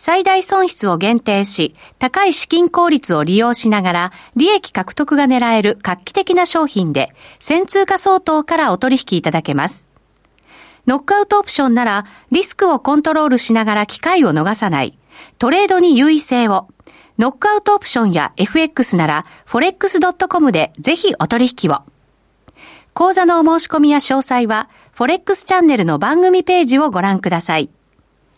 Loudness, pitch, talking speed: -14 LUFS, 280 Hz, 340 characters per minute